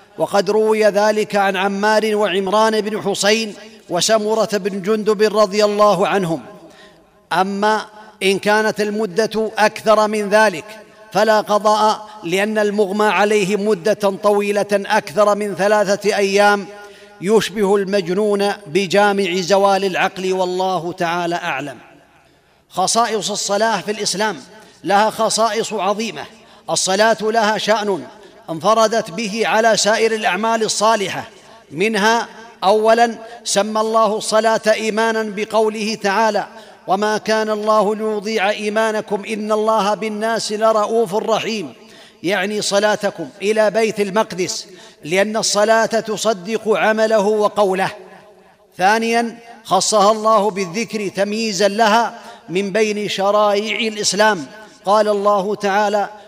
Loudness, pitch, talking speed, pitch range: -17 LUFS, 210 Hz, 105 wpm, 200-220 Hz